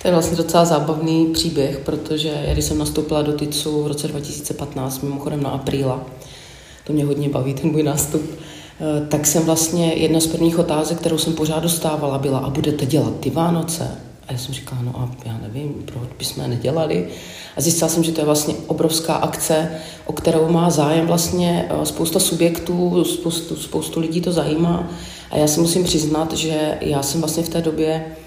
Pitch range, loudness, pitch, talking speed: 145-165 Hz, -19 LUFS, 155 Hz, 185 wpm